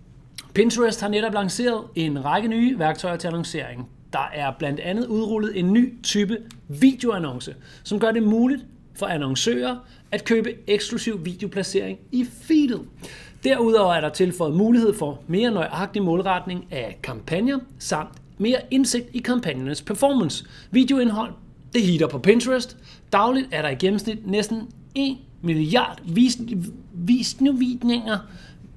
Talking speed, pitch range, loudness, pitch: 130 wpm, 170-240 Hz, -22 LUFS, 210 Hz